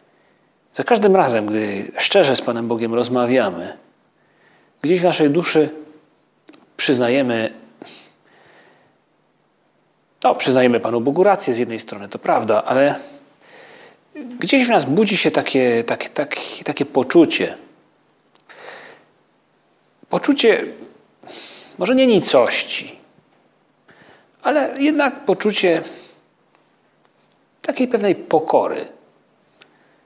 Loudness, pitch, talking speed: -17 LUFS, 175 Hz, 90 wpm